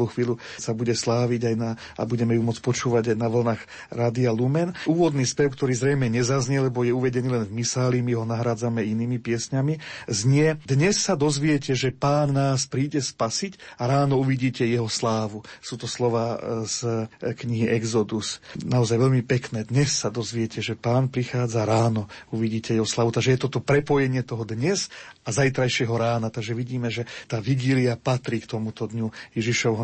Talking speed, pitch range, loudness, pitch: 170 wpm, 115-135 Hz, -24 LUFS, 120 Hz